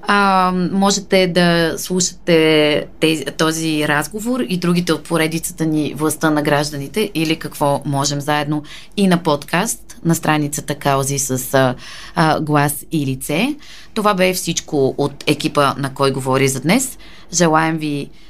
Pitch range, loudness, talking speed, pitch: 145-180 Hz, -17 LUFS, 140 wpm, 155 Hz